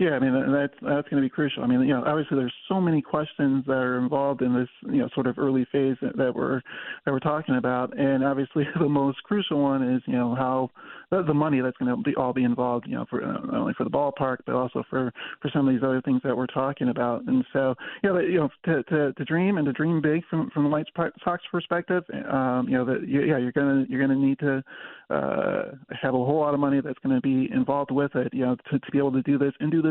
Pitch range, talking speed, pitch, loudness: 130-155 Hz, 275 wpm, 140 Hz, -25 LUFS